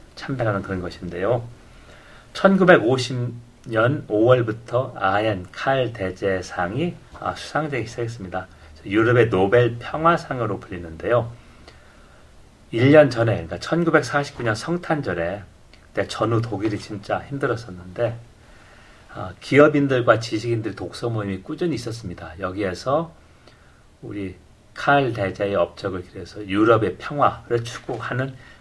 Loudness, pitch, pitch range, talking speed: -22 LUFS, 115 Hz, 95-125 Hz, 250 characters per minute